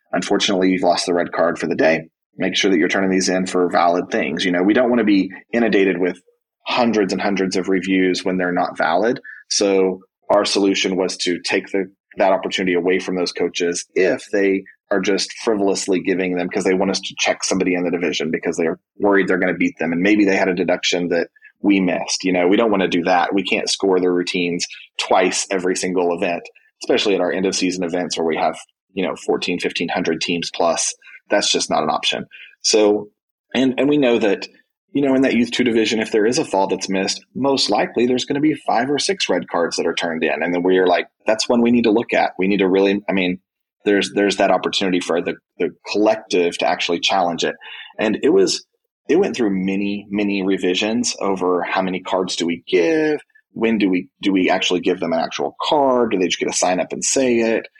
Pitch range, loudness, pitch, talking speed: 90-110 Hz, -18 LUFS, 95 Hz, 235 wpm